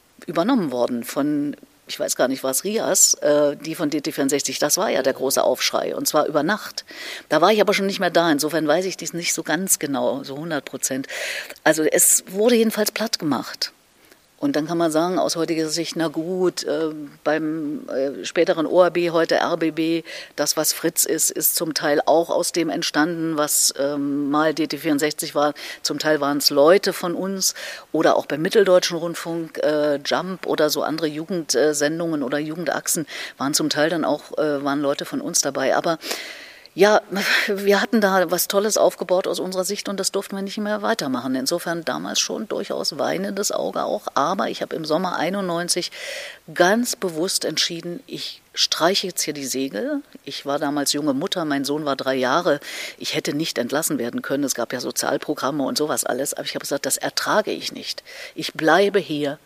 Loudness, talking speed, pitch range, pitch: -21 LUFS, 185 wpm, 150-190 Hz, 165 Hz